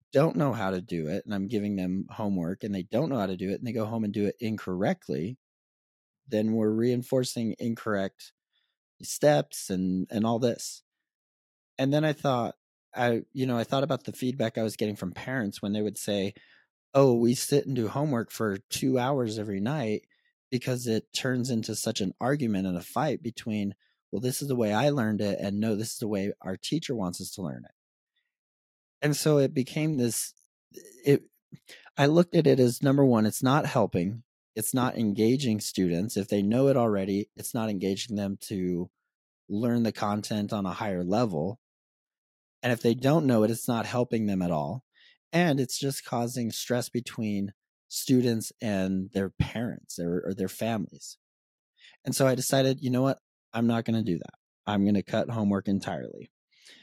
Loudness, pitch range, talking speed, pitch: -28 LUFS, 100-125 Hz, 190 wpm, 110 Hz